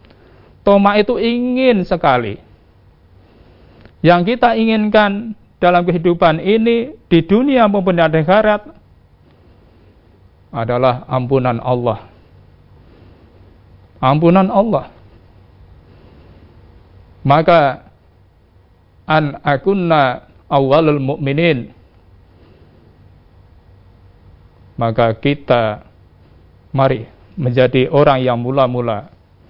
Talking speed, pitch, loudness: 65 wpm, 115 Hz, -14 LUFS